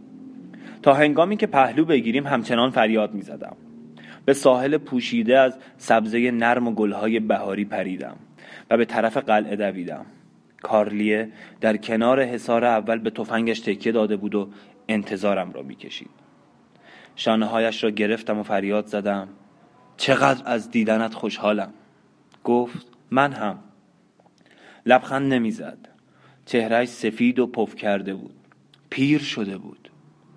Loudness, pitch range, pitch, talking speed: -22 LUFS, 105-125 Hz, 115 Hz, 125 wpm